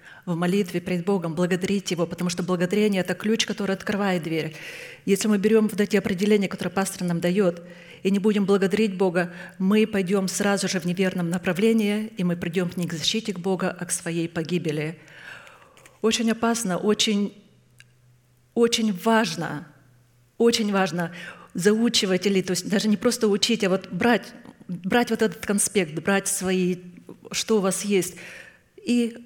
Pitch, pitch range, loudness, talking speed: 195 Hz, 180-210 Hz, -24 LUFS, 160 wpm